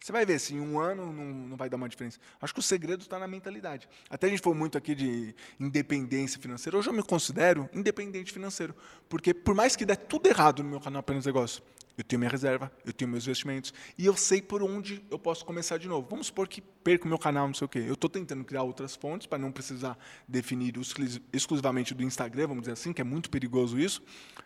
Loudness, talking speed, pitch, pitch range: -31 LUFS, 240 wpm, 145 Hz, 130-185 Hz